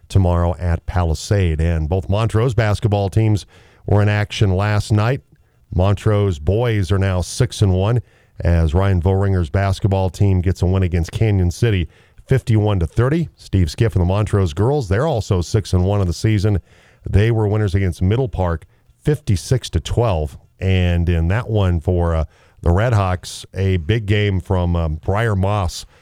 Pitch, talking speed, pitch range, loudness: 100 Hz, 165 wpm, 90-110 Hz, -18 LUFS